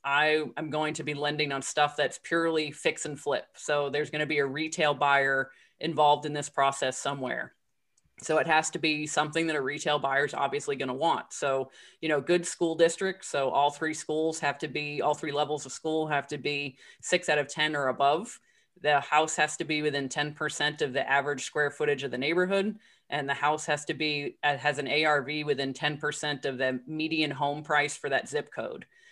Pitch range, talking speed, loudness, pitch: 145-155 Hz, 210 wpm, -28 LUFS, 150 Hz